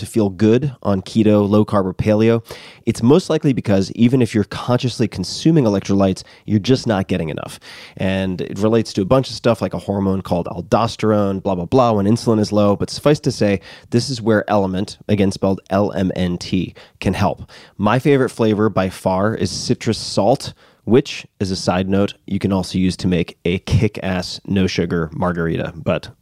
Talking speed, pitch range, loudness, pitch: 185 wpm, 95-115 Hz, -18 LUFS, 100 Hz